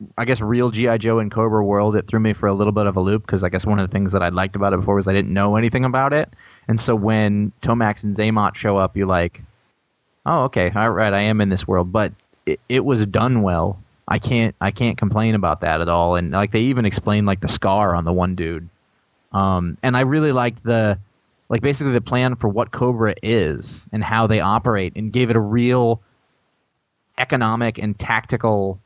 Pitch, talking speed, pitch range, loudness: 105 Hz, 230 wpm, 100-115 Hz, -19 LUFS